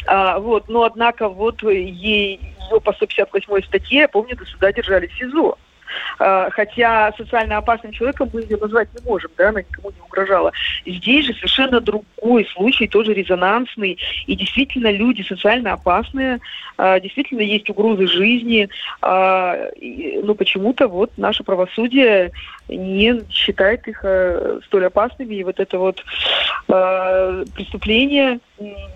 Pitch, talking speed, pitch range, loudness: 210 Hz, 140 wpm, 195-235 Hz, -17 LUFS